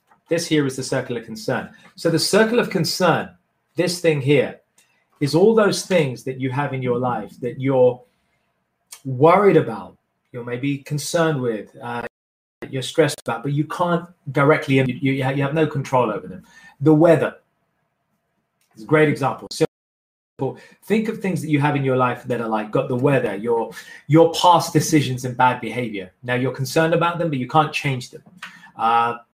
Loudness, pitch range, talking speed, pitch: -20 LUFS, 125-165 Hz, 180 wpm, 140 Hz